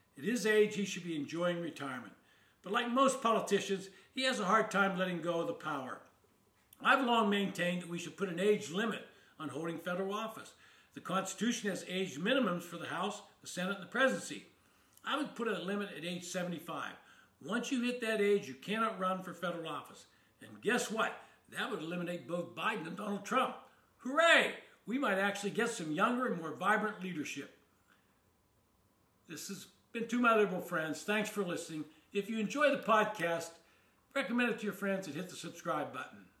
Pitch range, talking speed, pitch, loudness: 170-220 Hz, 190 wpm, 195 Hz, -35 LUFS